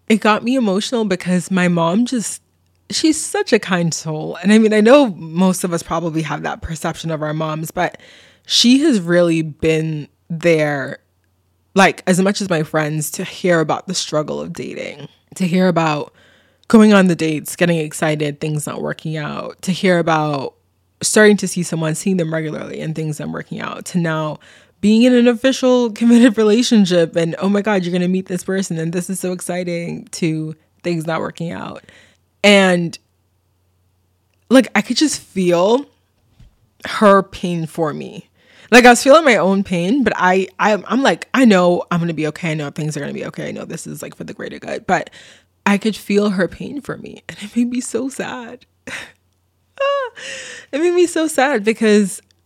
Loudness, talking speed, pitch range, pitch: -16 LUFS, 190 wpm, 160-215 Hz, 180 Hz